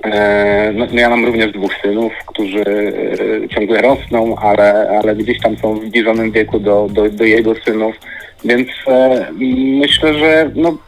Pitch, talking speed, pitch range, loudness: 110 Hz, 155 wpm, 105-120 Hz, -13 LUFS